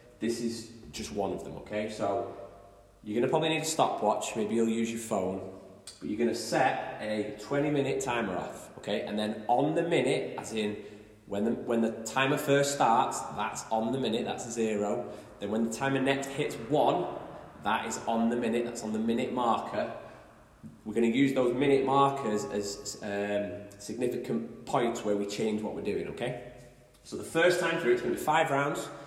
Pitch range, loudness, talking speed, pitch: 105-135 Hz, -30 LUFS, 195 wpm, 115 Hz